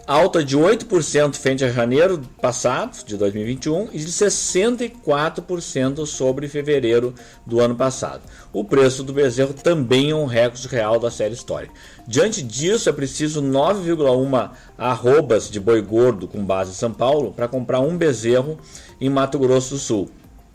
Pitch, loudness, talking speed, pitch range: 135 Hz, -19 LUFS, 150 wpm, 120-150 Hz